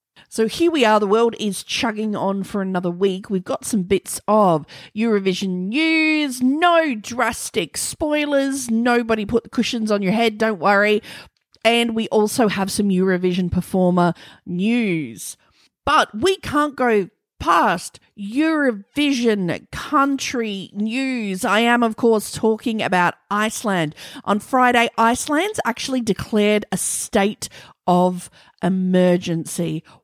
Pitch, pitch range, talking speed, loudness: 215 Hz, 190-240 Hz, 125 wpm, -19 LUFS